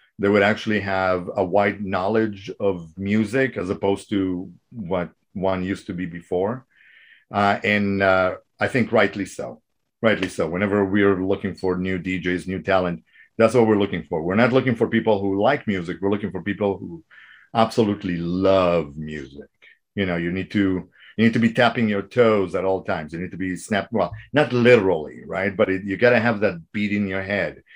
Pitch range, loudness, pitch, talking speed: 95-105 Hz, -21 LUFS, 100 Hz, 195 wpm